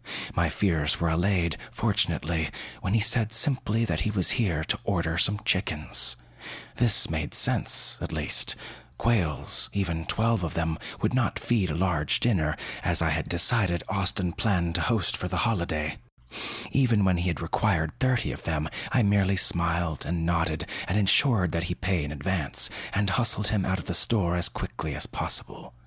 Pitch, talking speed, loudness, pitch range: 95 Hz, 175 wpm, -25 LUFS, 85-110 Hz